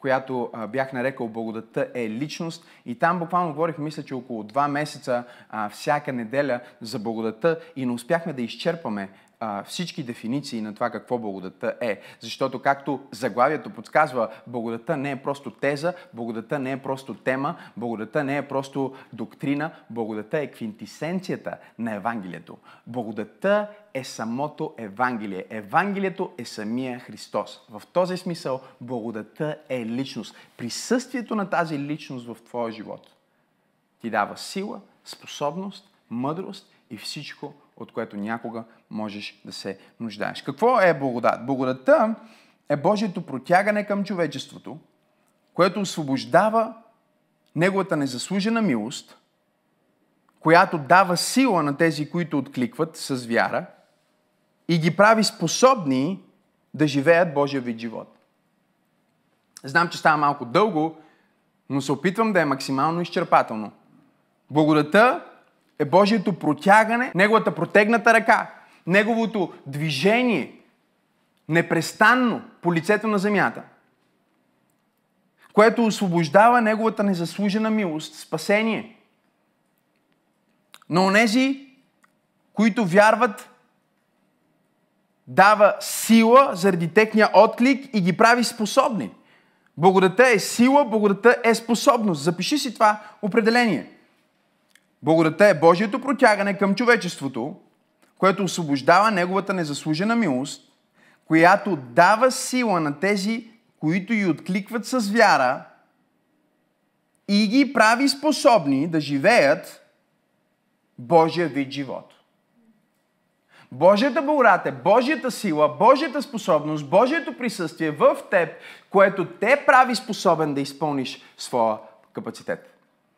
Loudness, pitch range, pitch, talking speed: -21 LUFS, 135-210 Hz, 170 Hz, 110 wpm